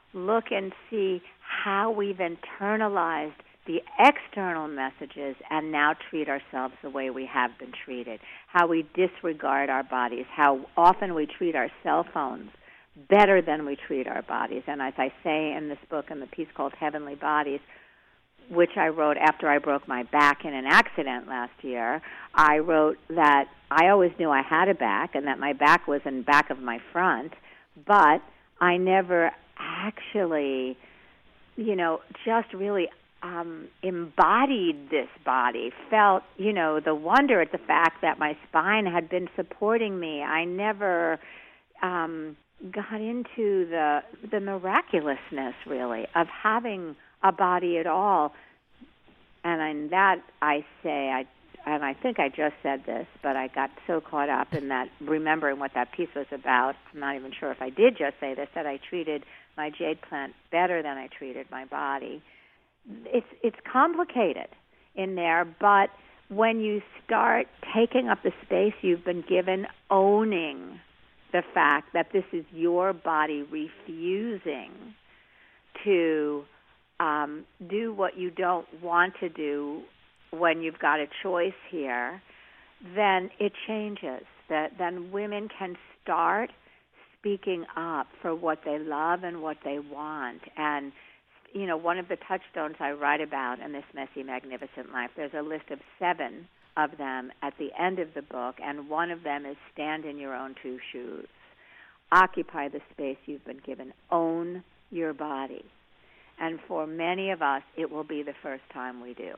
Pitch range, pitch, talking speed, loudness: 145-185 Hz, 160 Hz, 160 wpm, -27 LUFS